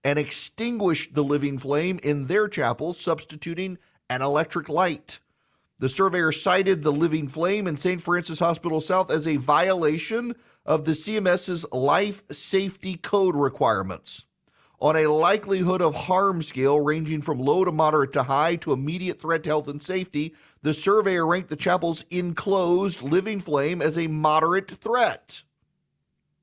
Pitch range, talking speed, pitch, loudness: 150-185 Hz, 150 wpm, 165 Hz, -24 LUFS